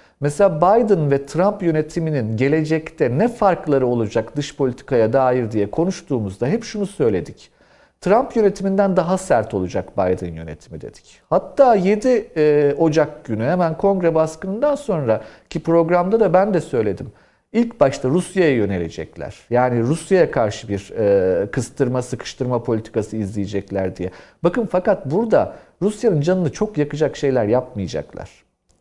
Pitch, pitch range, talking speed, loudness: 155 Hz, 120-195 Hz, 125 wpm, -19 LUFS